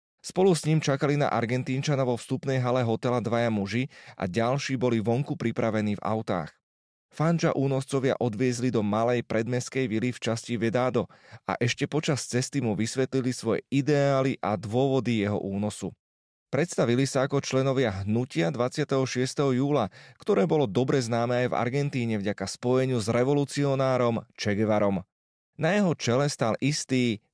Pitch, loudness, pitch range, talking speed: 125 Hz, -27 LUFS, 110-135 Hz, 145 wpm